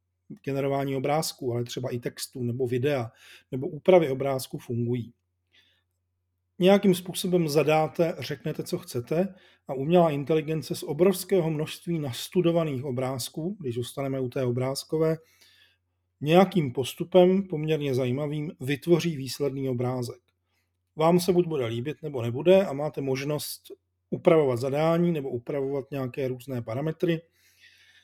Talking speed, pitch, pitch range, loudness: 120 wpm, 140 Hz, 125-165 Hz, -26 LUFS